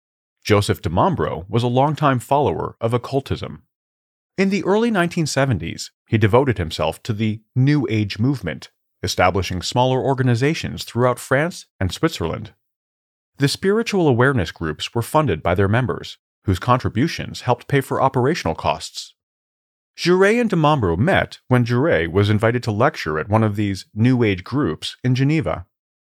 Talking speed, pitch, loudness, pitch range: 145 wpm, 120 Hz, -19 LUFS, 100-140 Hz